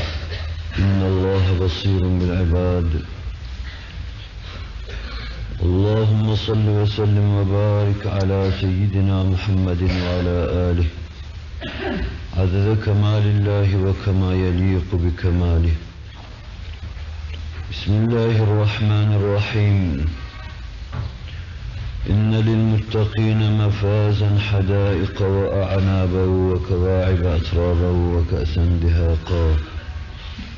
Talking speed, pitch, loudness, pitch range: 65 wpm, 95 Hz, -20 LUFS, 85-100 Hz